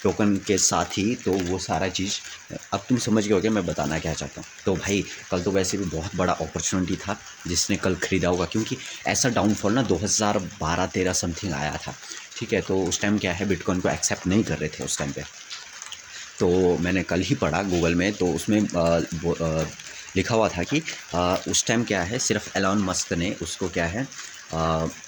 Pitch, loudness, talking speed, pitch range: 95 Hz, -24 LUFS, 205 wpm, 85-100 Hz